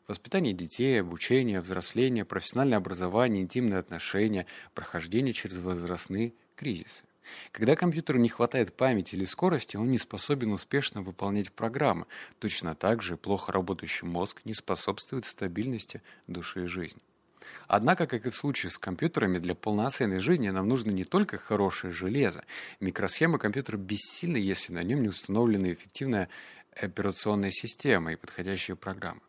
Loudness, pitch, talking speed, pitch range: -30 LUFS, 100 Hz, 135 wpm, 95-120 Hz